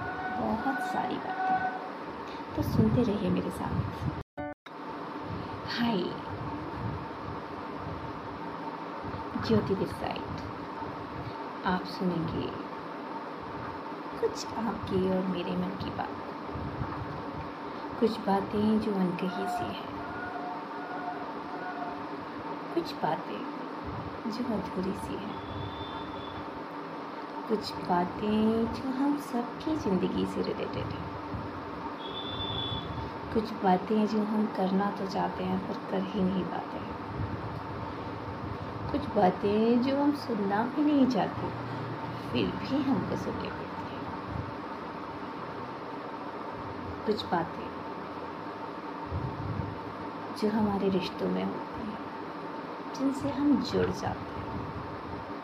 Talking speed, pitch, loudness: 90 wpm, 185 Hz, -33 LUFS